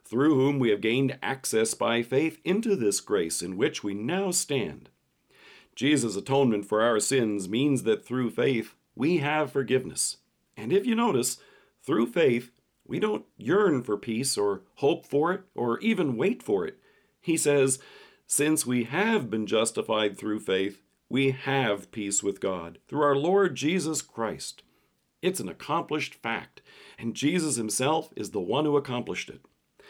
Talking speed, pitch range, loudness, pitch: 160 wpm, 110-160 Hz, -27 LUFS, 135 Hz